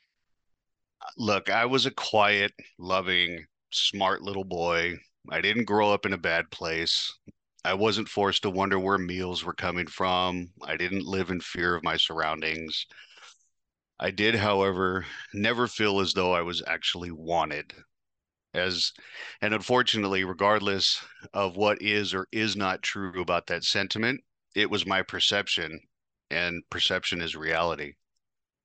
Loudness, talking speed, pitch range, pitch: -27 LUFS, 140 wpm, 85-100 Hz, 95 Hz